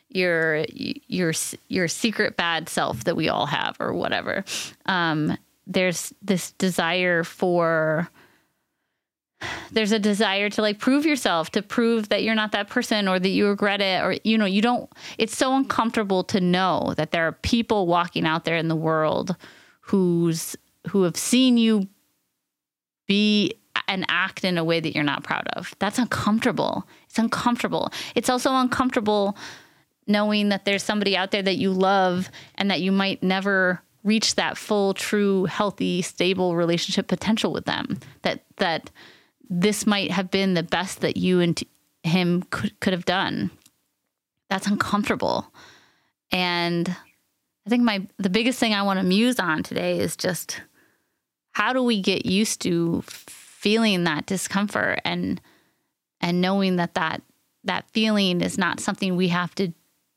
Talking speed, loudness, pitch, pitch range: 160 wpm, -23 LUFS, 195 Hz, 175-215 Hz